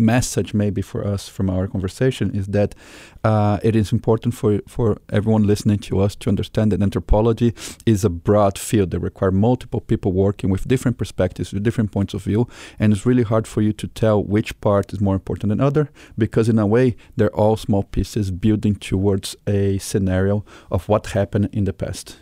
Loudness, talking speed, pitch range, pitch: -20 LUFS, 195 wpm, 100-110 Hz, 105 Hz